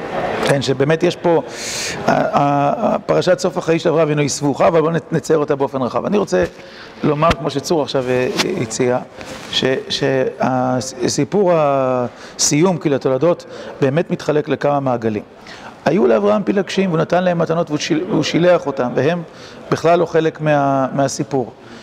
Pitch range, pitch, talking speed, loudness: 135-165 Hz, 145 Hz, 130 wpm, -17 LUFS